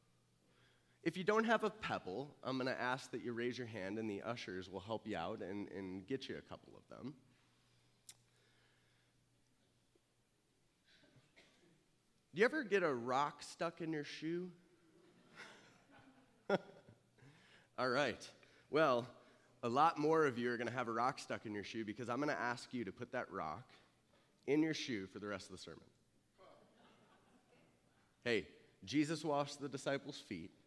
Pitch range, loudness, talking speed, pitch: 105-145 Hz, -41 LUFS, 160 wpm, 125 Hz